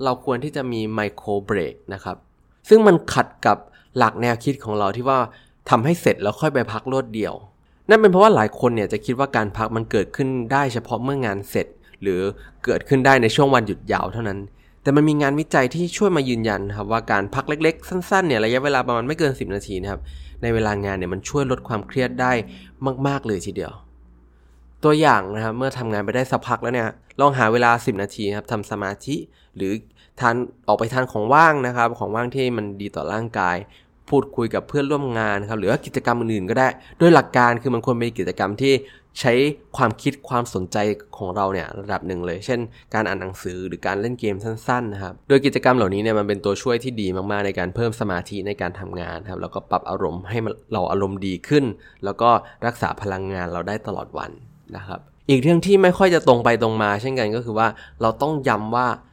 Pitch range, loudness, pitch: 100-130 Hz, -21 LUFS, 115 Hz